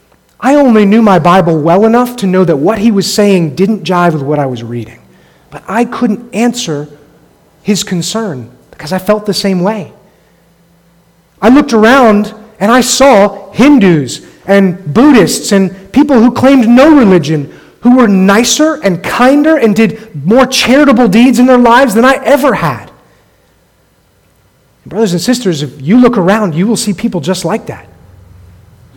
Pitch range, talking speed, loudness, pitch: 170-240 Hz, 165 wpm, -8 LUFS, 205 Hz